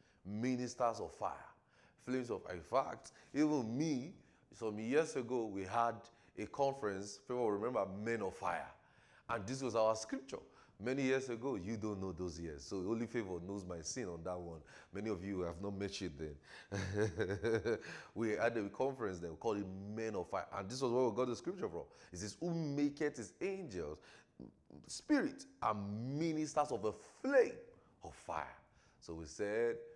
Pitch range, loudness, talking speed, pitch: 100-130 Hz, -40 LUFS, 180 wpm, 115 Hz